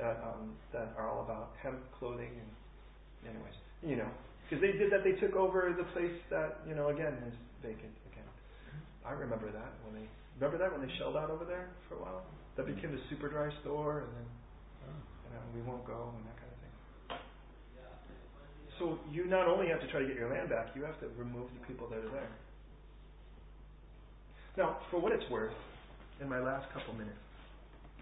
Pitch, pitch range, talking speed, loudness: 130 Hz, 115-155 Hz, 205 wpm, -39 LUFS